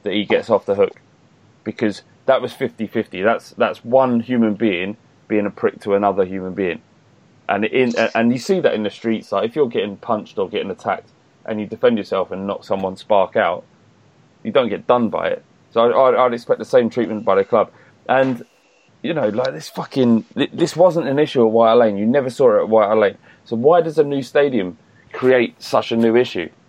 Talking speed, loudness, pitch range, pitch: 215 wpm, -18 LUFS, 110-135 Hz, 120 Hz